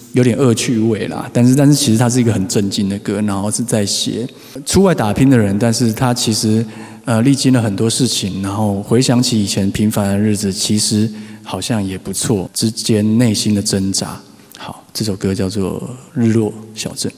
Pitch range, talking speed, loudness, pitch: 105-120 Hz, 285 characters per minute, -15 LUFS, 110 Hz